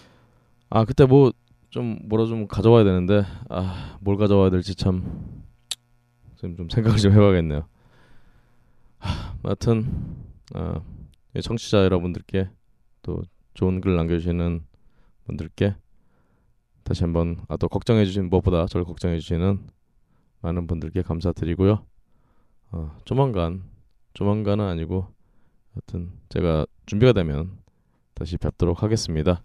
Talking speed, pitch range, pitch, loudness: 255 characters per minute, 85-110 Hz, 95 Hz, -23 LUFS